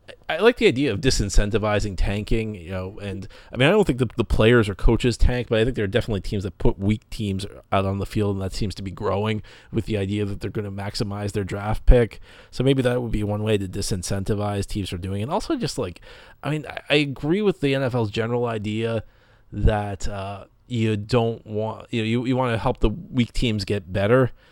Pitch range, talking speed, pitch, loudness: 100-120 Hz, 235 wpm, 110 Hz, -24 LUFS